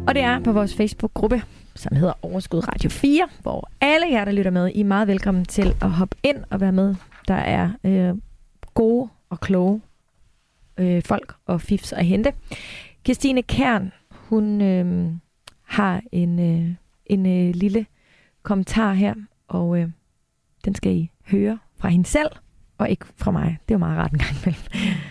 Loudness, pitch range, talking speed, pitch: -22 LUFS, 180-220 Hz, 170 wpm, 195 Hz